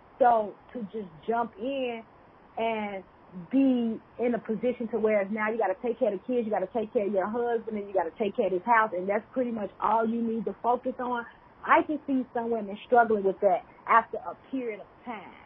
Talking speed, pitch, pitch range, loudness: 225 wpm, 225 Hz, 205-240 Hz, -28 LUFS